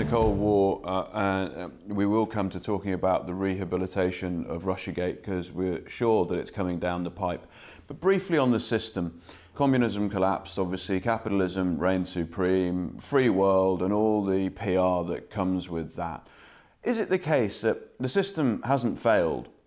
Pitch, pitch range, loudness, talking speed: 95 Hz, 90-105 Hz, -27 LUFS, 170 wpm